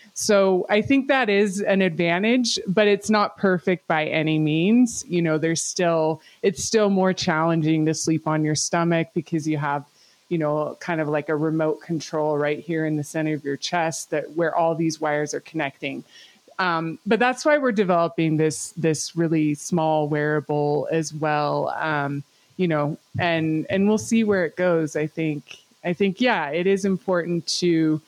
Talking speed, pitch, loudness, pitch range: 180 wpm, 165 Hz, -22 LUFS, 155-185 Hz